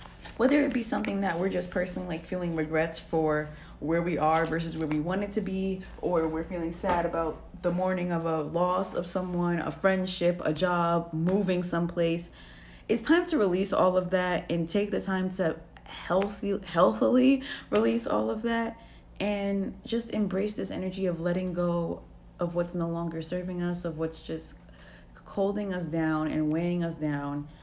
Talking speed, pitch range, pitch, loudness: 175 wpm, 165-190 Hz, 175 Hz, -29 LUFS